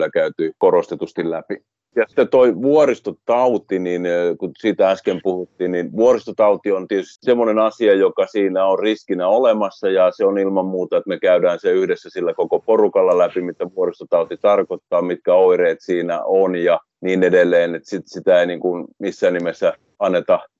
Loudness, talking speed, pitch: -18 LUFS, 165 wpm, 110 Hz